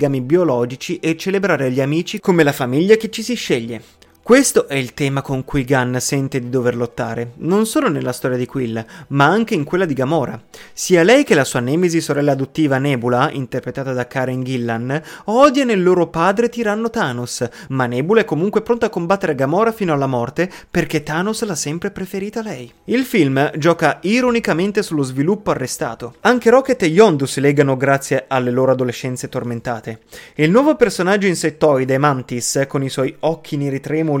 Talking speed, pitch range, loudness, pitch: 175 wpm, 130-195 Hz, -17 LUFS, 150 Hz